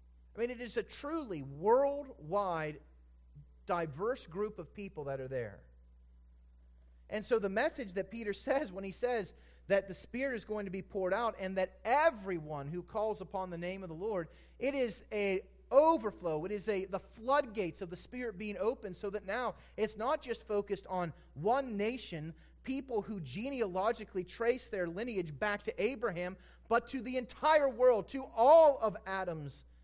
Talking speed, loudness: 175 wpm, -35 LUFS